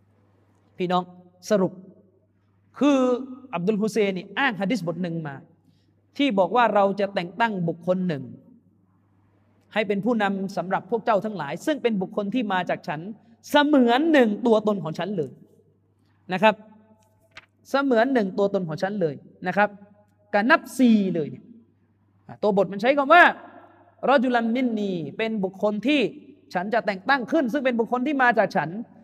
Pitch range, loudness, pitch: 170-240 Hz, -23 LUFS, 200 Hz